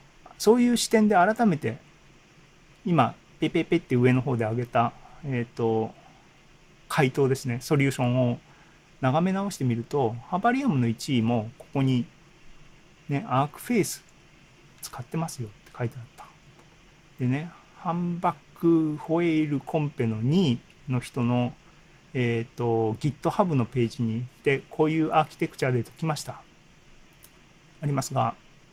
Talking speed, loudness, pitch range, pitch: 290 characters per minute, -26 LUFS, 125-165 Hz, 145 Hz